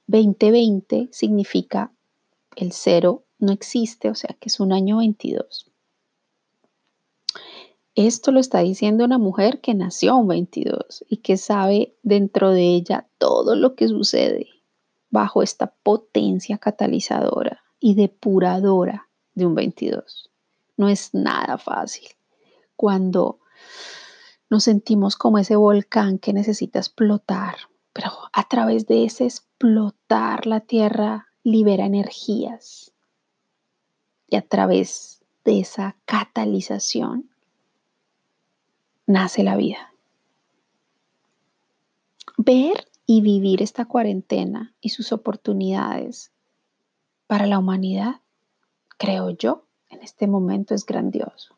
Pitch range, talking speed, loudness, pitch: 195-235 Hz, 105 wpm, -20 LUFS, 210 Hz